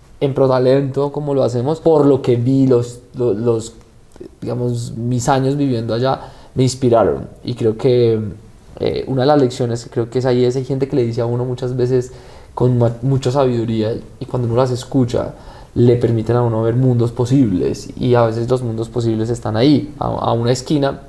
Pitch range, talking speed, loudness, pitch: 115-130 Hz, 195 wpm, -17 LUFS, 125 Hz